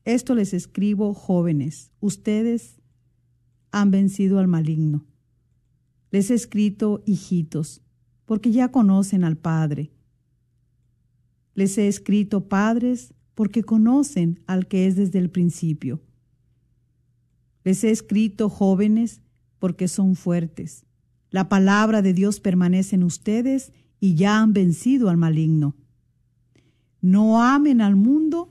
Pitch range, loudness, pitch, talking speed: 130-210 Hz, -21 LUFS, 185 Hz, 115 wpm